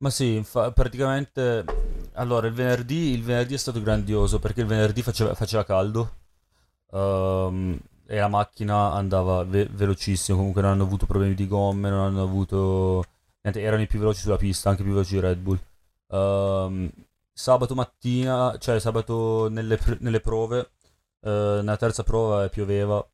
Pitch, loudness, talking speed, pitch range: 105 Hz, -25 LUFS, 165 wpm, 95-115 Hz